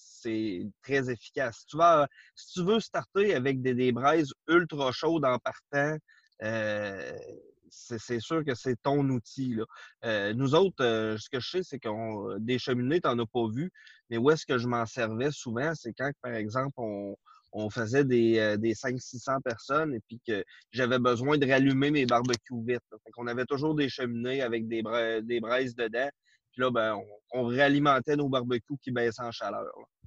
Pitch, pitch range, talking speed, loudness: 125 Hz, 115-140 Hz, 195 wpm, -29 LUFS